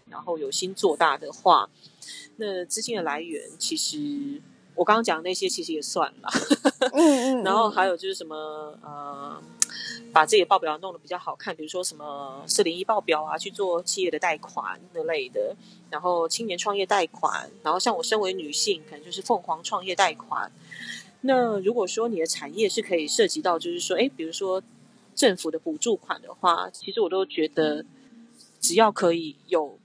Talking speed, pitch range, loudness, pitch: 270 characters per minute, 165-240 Hz, -25 LUFS, 195 Hz